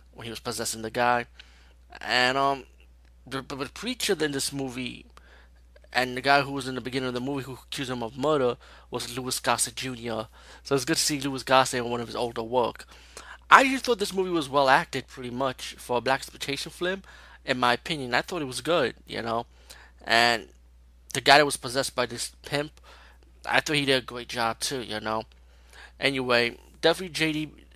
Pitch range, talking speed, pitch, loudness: 115-140 Hz, 205 wpm, 130 Hz, -26 LUFS